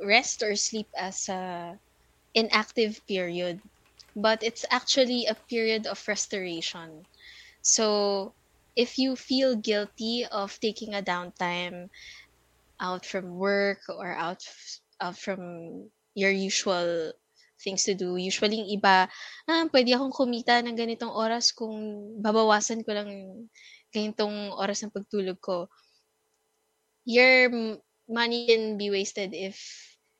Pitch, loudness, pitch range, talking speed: 210 Hz, -27 LUFS, 195-230 Hz, 120 wpm